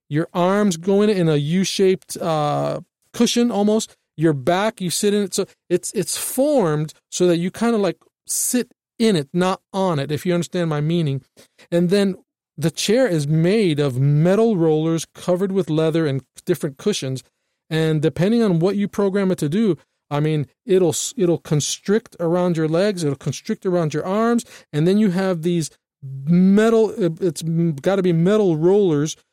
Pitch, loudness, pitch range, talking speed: 175 Hz, -19 LUFS, 160-200 Hz, 180 wpm